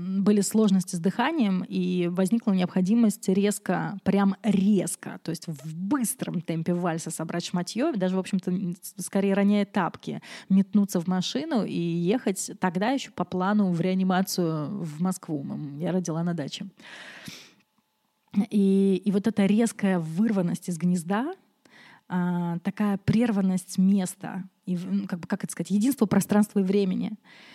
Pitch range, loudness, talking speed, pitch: 180-205 Hz, -26 LUFS, 135 wpm, 195 Hz